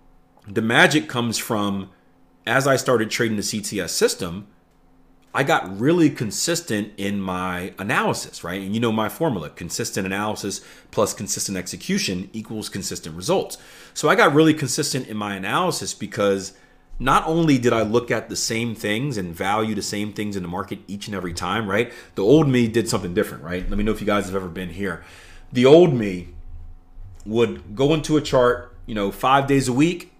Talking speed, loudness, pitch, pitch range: 185 wpm, -21 LUFS, 105 Hz, 95-125 Hz